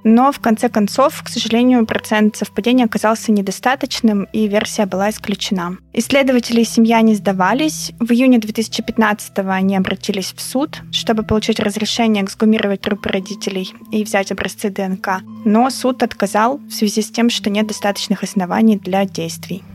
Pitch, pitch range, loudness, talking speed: 215 Hz, 200-230 Hz, -16 LUFS, 150 wpm